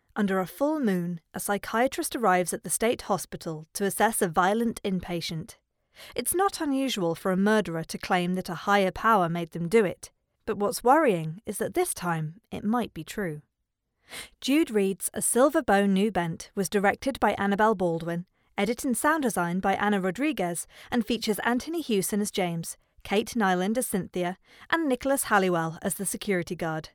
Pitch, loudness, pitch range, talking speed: 200 Hz, -27 LUFS, 180-235 Hz, 175 wpm